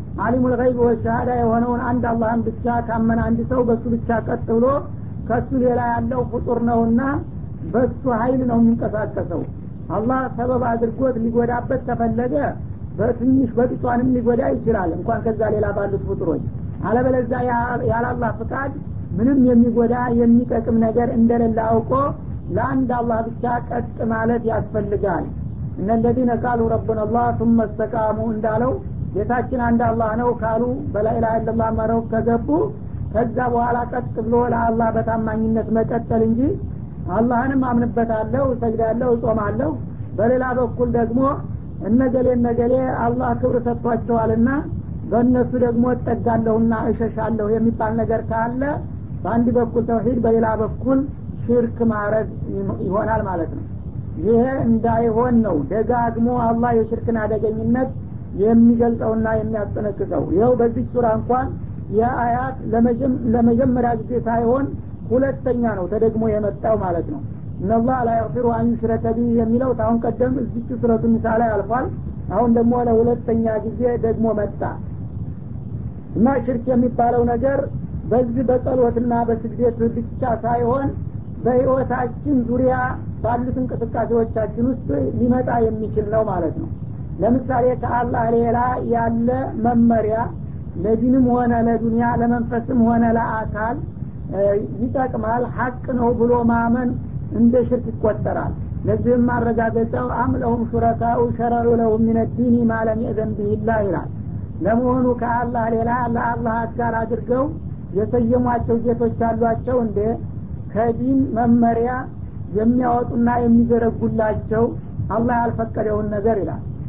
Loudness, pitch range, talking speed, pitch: -20 LUFS, 225-245 Hz, 110 wpm, 235 Hz